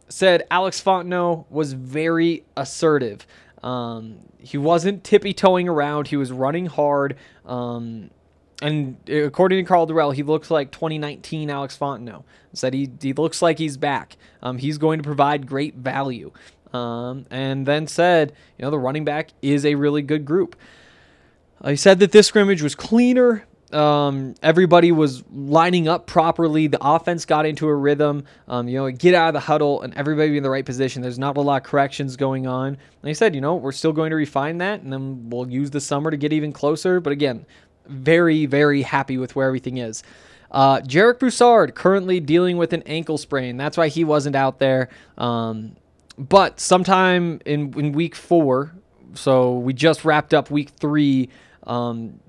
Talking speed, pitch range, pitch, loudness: 180 wpm, 135-165 Hz, 150 Hz, -19 LUFS